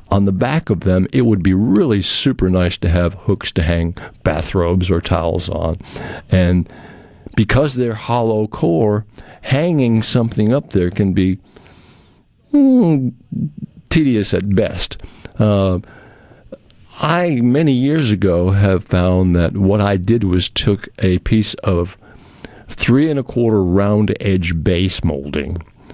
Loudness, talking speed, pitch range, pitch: -16 LUFS, 135 wpm, 90-115 Hz, 100 Hz